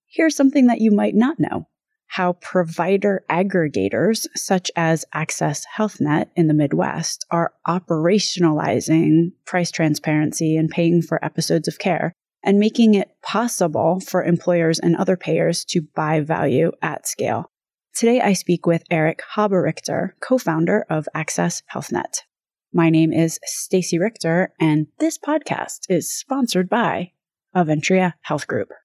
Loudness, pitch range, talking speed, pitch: -20 LUFS, 160-205 Hz, 135 wpm, 175 Hz